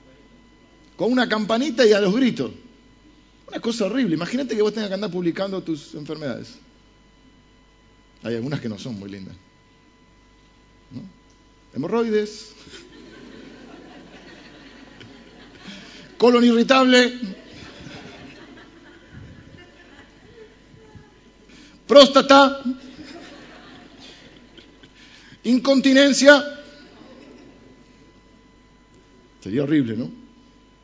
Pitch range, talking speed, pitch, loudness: 200-270 Hz, 70 wpm, 240 Hz, -18 LUFS